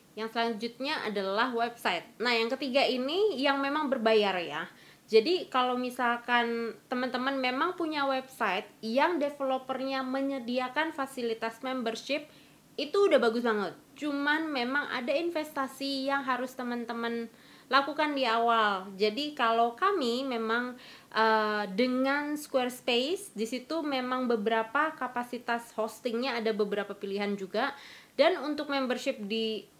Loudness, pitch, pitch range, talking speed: -30 LUFS, 250 Hz, 230-275 Hz, 120 wpm